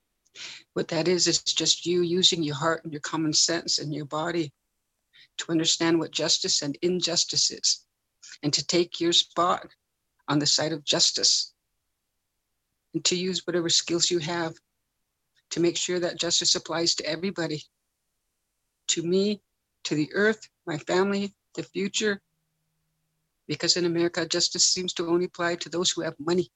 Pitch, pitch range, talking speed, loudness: 170 Hz, 160-175 Hz, 160 wpm, -25 LUFS